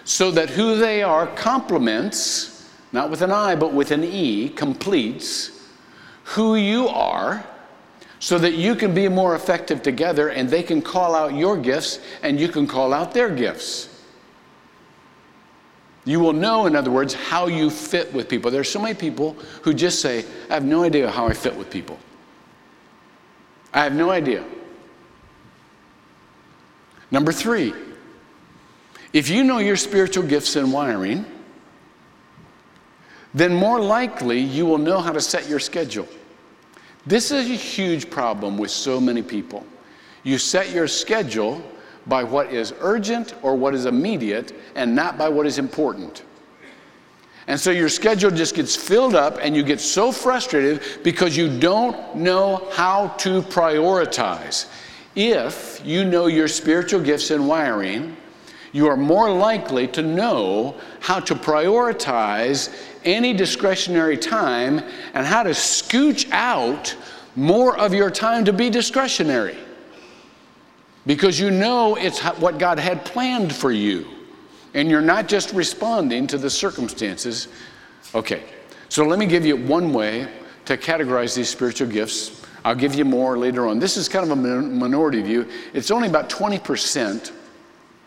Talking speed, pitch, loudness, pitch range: 150 wpm, 170 Hz, -20 LUFS, 145-205 Hz